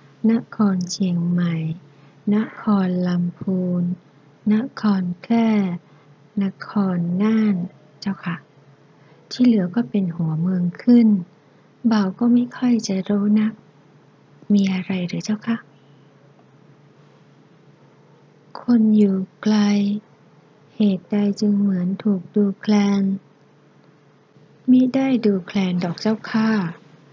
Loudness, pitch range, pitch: -20 LUFS, 175-215 Hz, 195 Hz